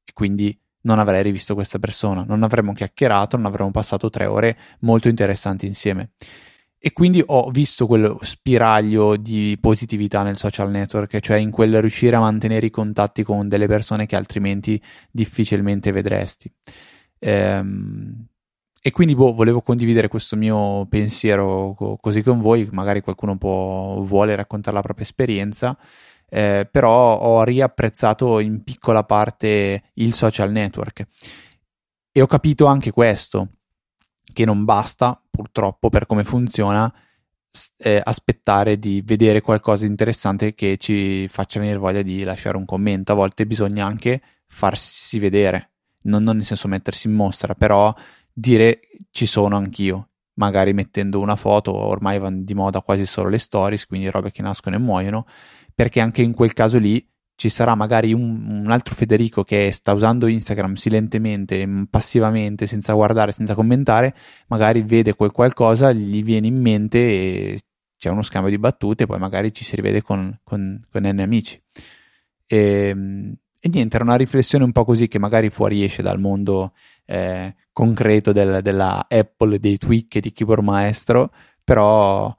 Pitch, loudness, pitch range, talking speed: 105 Hz, -18 LUFS, 100-115 Hz, 150 wpm